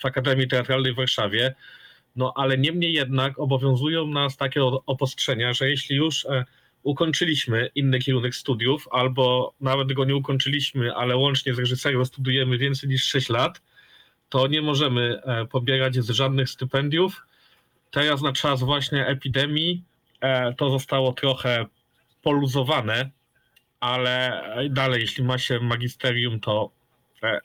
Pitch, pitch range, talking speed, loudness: 135 Hz, 125-140 Hz, 135 wpm, -23 LUFS